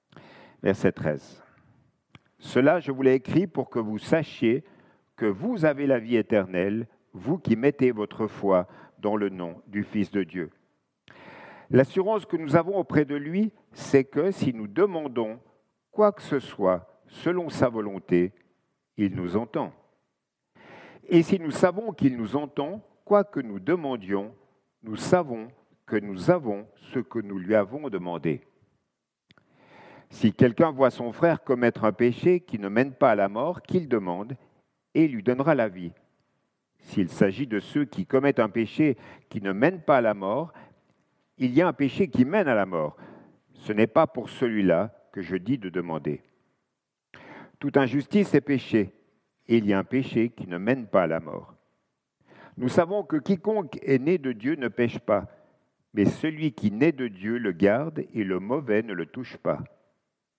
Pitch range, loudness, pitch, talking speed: 105-160 Hz, -26 LUFS, 130 Hz, 170 wpm